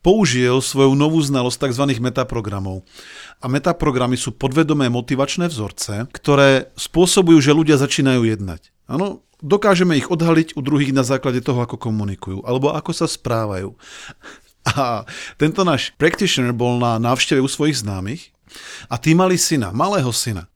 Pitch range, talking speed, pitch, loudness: 120-155 Hz, 145 wpm, 135 Hz, -17 LUFS